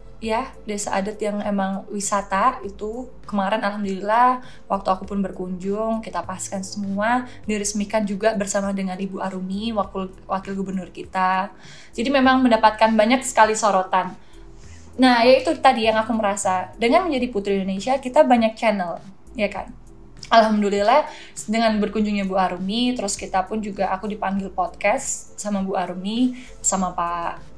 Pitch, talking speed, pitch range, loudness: 205 Hz, 140 wpm, 190-225 Hz, -21 LUFS